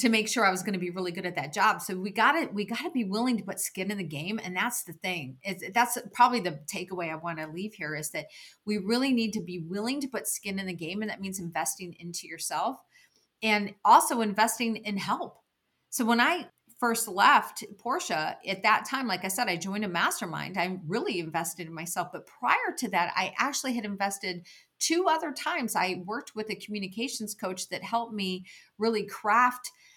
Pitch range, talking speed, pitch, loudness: 185-235 Hz, 220 wpm, 205 Hz, -29 LUFS